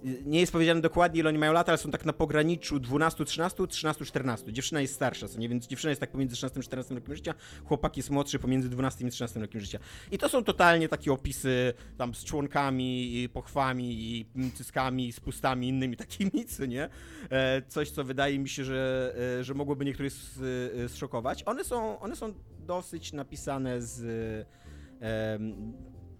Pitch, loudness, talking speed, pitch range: 130 Hz, -31 LUFS, 175 wpm, 125-150 Hz